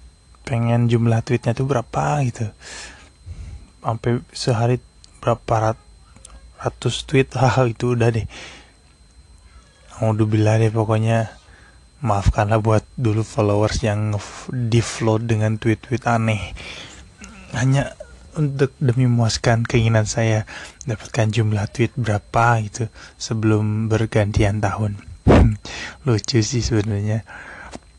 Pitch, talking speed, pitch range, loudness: 110 Hz, 105 wpm, 100-115 Hz, -20 LUFS